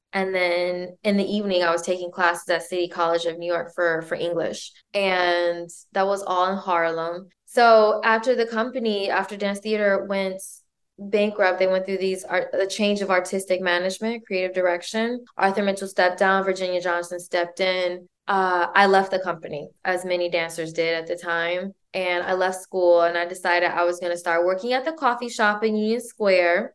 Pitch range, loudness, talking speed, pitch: 175-200 Hz, -23 LUFS, 190 wpm, 185 Hz